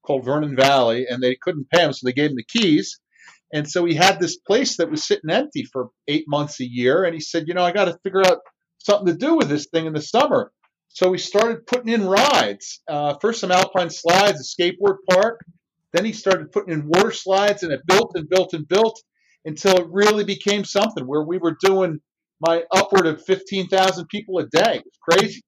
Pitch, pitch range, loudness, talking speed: 180 Hz, 160-200 Hz, -19 LUFS, 225 wpm